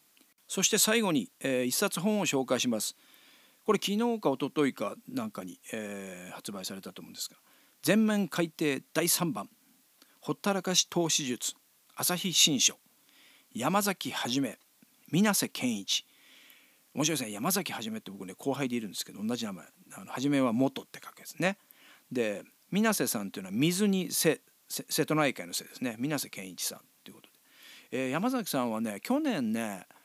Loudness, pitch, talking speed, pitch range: -30 LUFS, 200 Hz, 325 characters per minute, 140-240 Hz